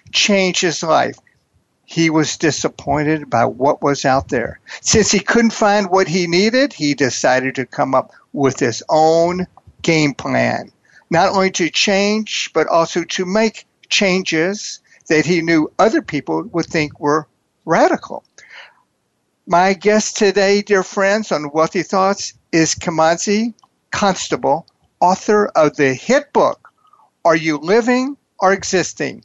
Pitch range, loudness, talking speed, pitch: 155-205 Hz, -16 LUFS, 135 wpm, 175 Hz